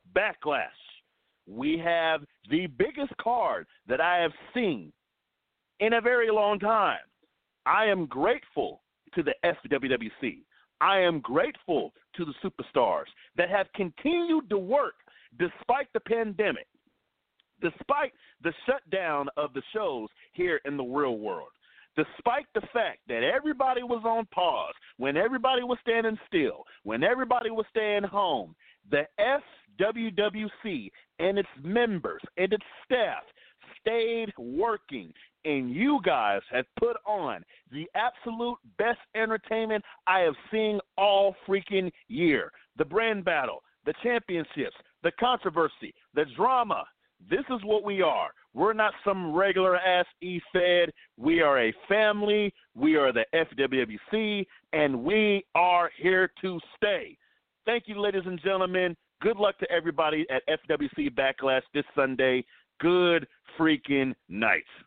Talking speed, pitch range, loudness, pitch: 130 wpm, 170-235 Hz, -28 LUFS, 205 Hz